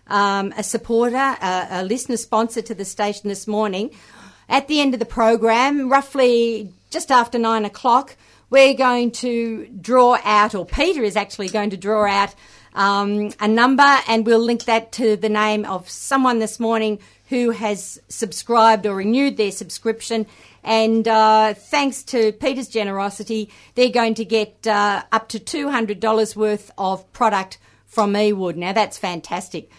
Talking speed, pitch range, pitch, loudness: 160 wpm, 210-240 Hz, 220 Hz, -19 LUFS